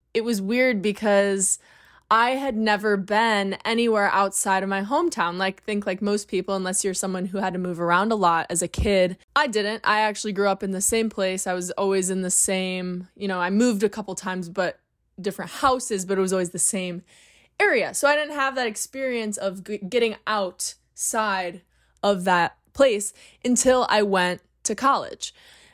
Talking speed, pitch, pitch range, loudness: 190 wpm, 200 Hz, 185-220 Hz, -23 LUFS